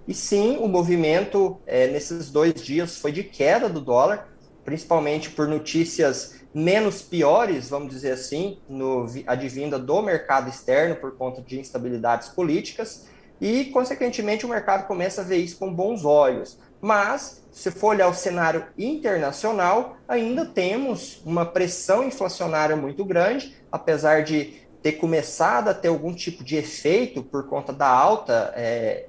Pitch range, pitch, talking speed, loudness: 150-205 Hz, 170 Hz, 145 wpm, -23 LUFS